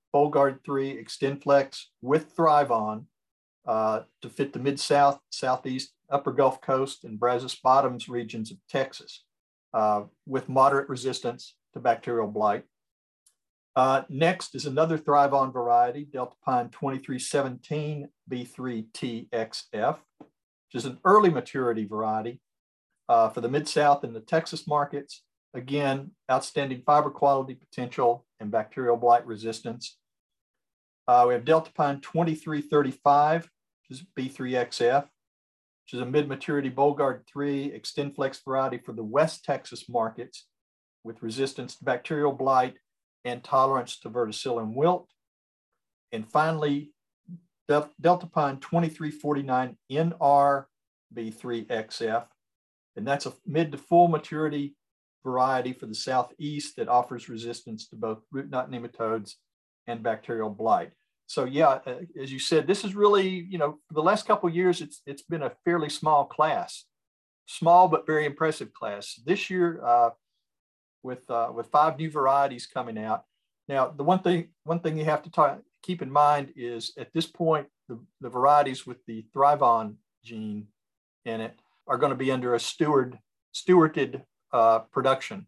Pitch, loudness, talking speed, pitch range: 135 Hz, -26 LUFS, 140 wpm, 120-150 Hz